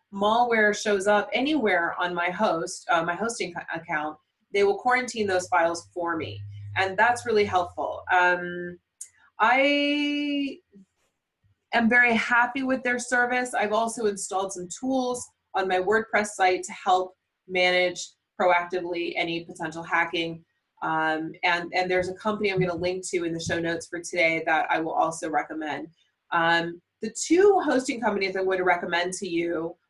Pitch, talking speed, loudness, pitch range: 185 Hz, 155 wpm, -25 LUFS, 170-225 Hz